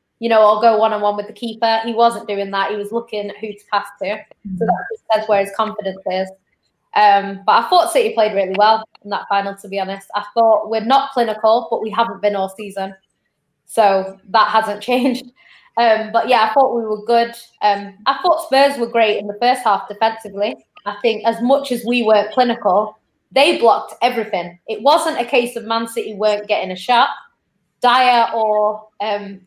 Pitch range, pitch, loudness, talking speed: 205-235 Hz, 220 Hz, -17 LUFS, 210 wpm